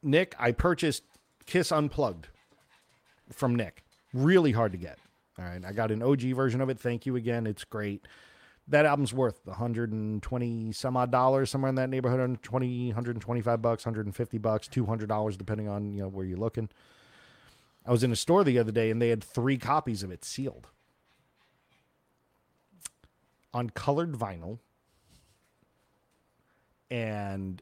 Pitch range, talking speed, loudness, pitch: 105-130 Hz, 150 wpm, -29 LUFS, 120 Hz